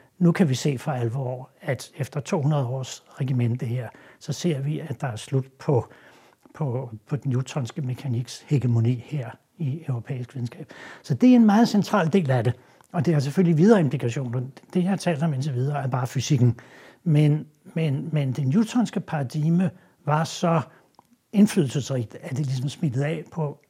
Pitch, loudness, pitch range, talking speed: 145 Hz, -24 LUFS, 130-165 Hz, 180 wpm